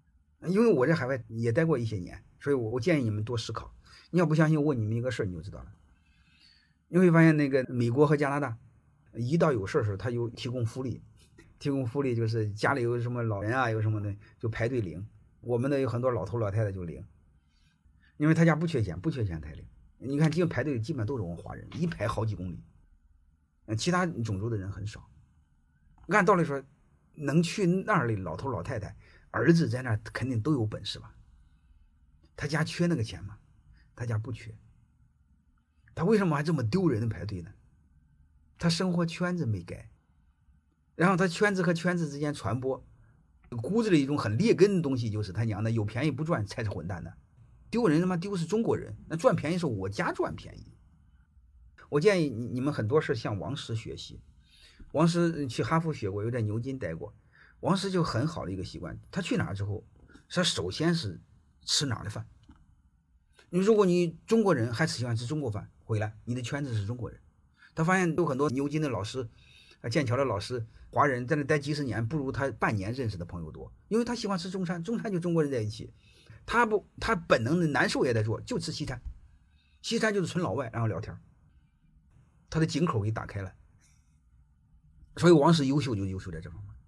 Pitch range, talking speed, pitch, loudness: 95-155 Hz, 295 characters per minute, 120 Hz, -29 LUFS